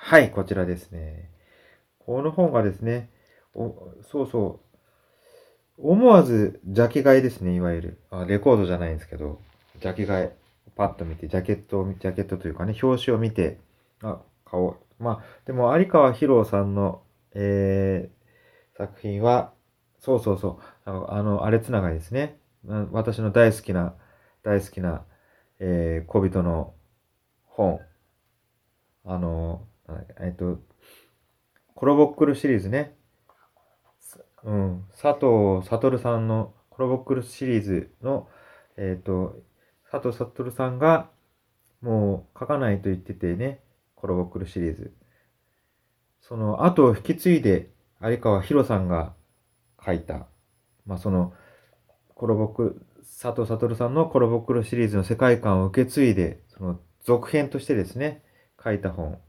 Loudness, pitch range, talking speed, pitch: -24 LUFS, 95-120 Hz, 260 characters per minute, 105 Hz